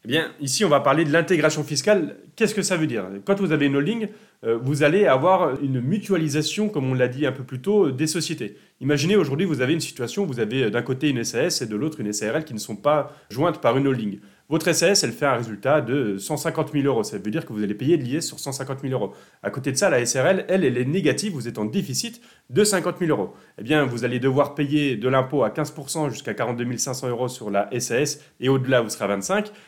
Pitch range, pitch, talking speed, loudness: 125-165 Hz, 145 Hz, 250 wpm, -22 LUFS